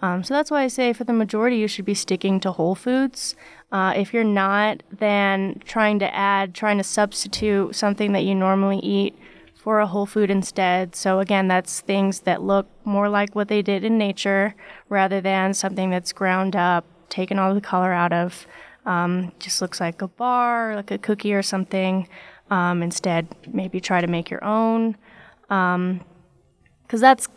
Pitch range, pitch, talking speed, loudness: 185-210 Hz, 195 Hz, 185 wpm, -22 LUFS